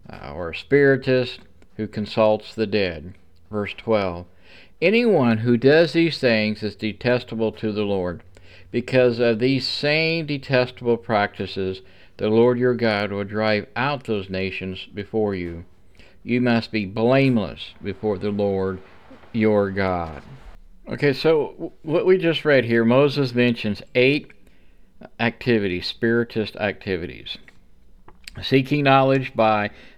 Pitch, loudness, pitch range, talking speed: 110 Hz, -21 LUFS, 95-125 Hz, 120 wpm